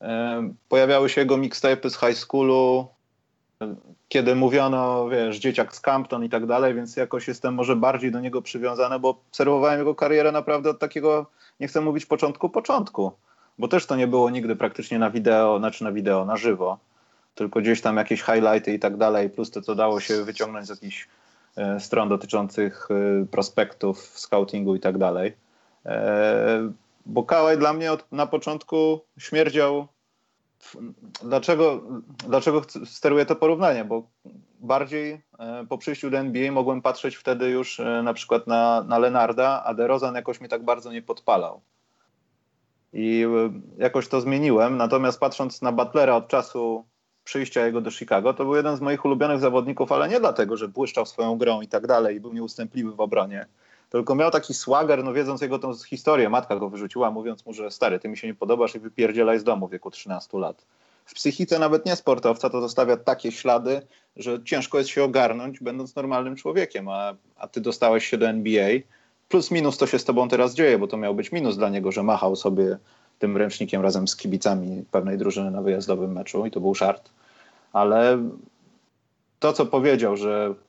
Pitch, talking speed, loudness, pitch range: 125 Hz, 175 wpm, -23 LUFS, 110-140 Hz